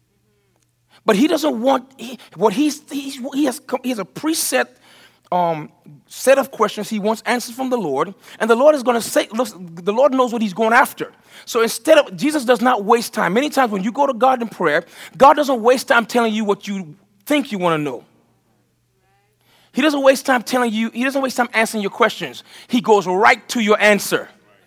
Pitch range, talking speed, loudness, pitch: 215-270 Hz, 215 wpm, -17 LUFS, 245 Hz